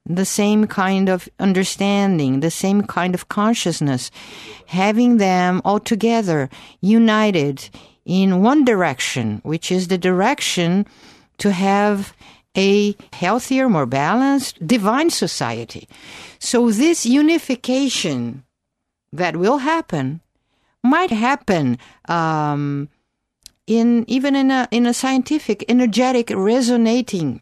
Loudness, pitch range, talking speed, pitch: -18 LUFS, 170-240 Hz, 105 wpm, 200 Hz